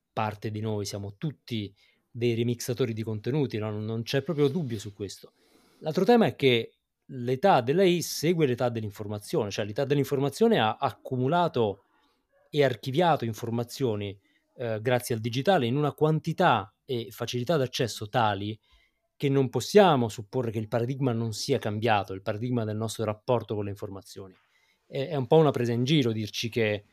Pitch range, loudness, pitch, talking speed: 110-140 Hz, -27 LUFS, 120 Hz, 160 wpm